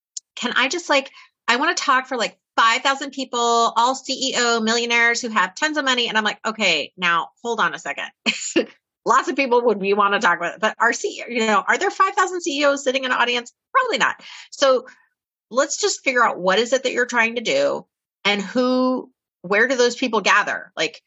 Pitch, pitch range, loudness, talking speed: 250 Hz, 230-280 Hz, -19 LUFS, 220 wpm